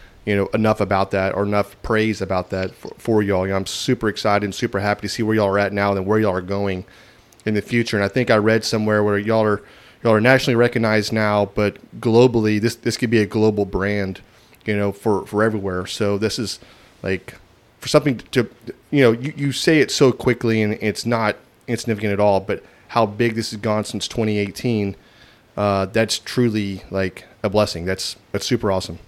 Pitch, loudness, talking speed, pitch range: 105 Hz, -20 LUFS, 215 wpm, 100-115 Hz